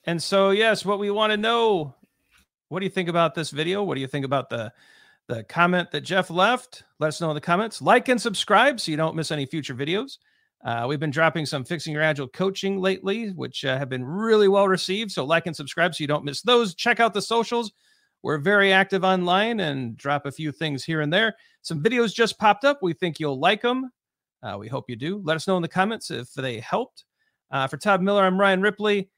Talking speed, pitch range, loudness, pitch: 235 wpm, 155-215 Hz, -23 LUFS, 185 Hz